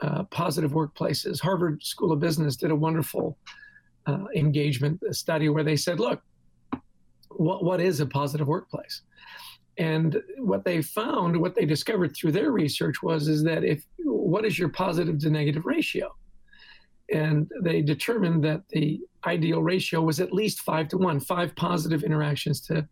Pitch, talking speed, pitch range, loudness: 160 Hz, 160 wpm, 150-180 Hz, -26 LUFS